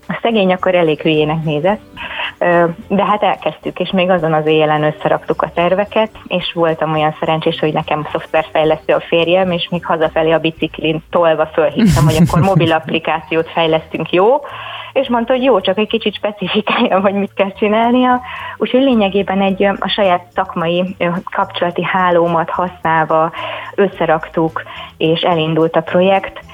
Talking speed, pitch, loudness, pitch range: 150 wpm, 175 Hz, -14 LUFS, 160-200 Hz